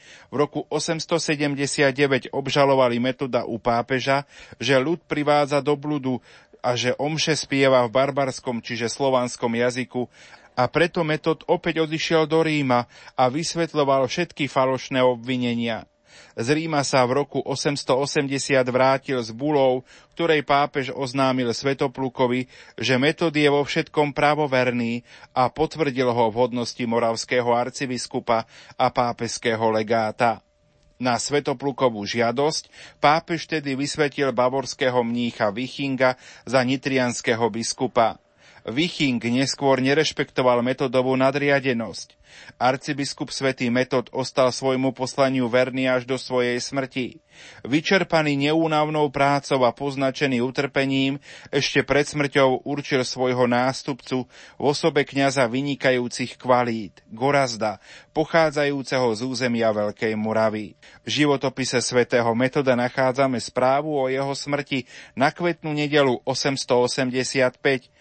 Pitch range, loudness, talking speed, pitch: 125-145 Hz, -22 LUFS, 110 wpm, 135 Hz